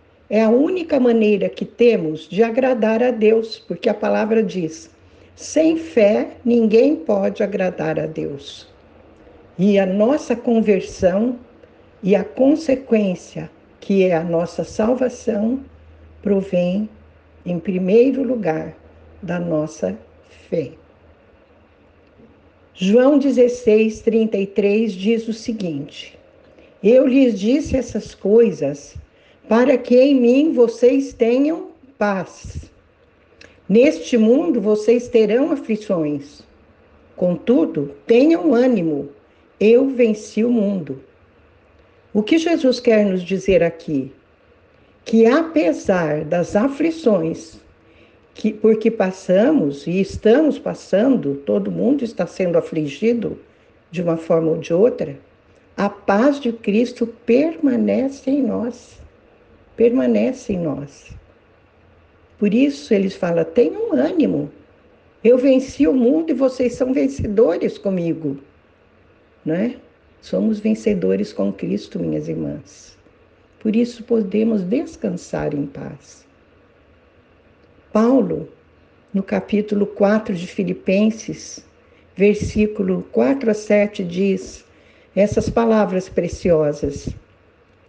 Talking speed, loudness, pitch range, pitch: 105 wpm, -18 LUFS, 170-245 Hz, 215 Hz